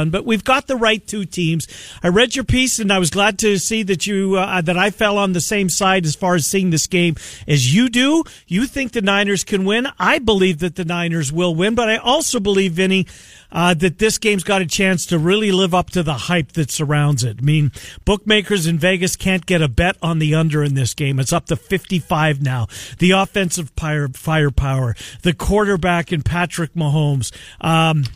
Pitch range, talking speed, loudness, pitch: 155-200 Hz, 215 wpm, -17 LUFS, 180 Hz